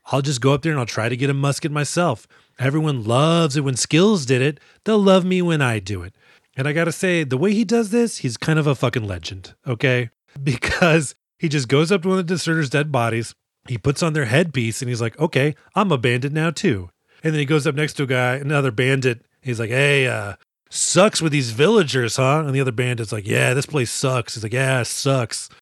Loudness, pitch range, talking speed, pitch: -19 LUFS, 125-160 Hz, 240 wpm, 140 Hz